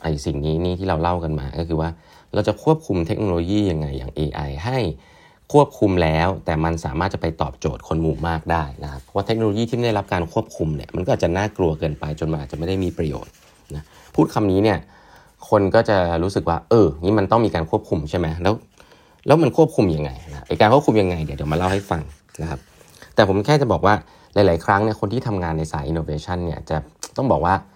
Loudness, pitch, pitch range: -21 LUFS, 85 Hz, 80-105 Hz